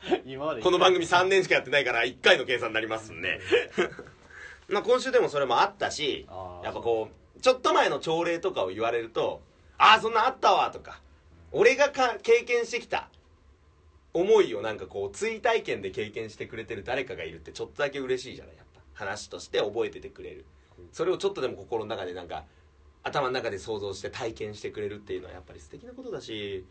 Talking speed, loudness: 405 characters per minute, -27 LUFS